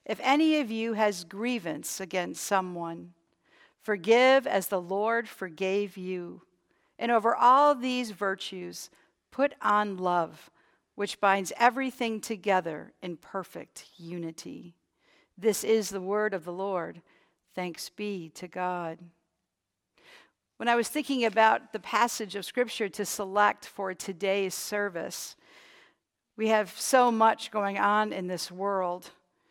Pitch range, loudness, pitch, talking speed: 185-225 Hz, -28 LUFS, 200 Hz, 130 wpm